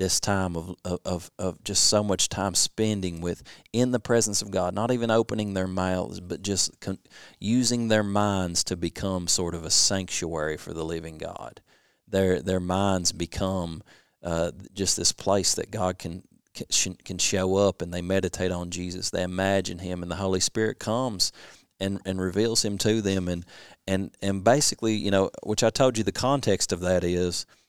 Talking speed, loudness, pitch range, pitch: 190 wpm, -26 LUFS, 90-105 Hz, 95 Hz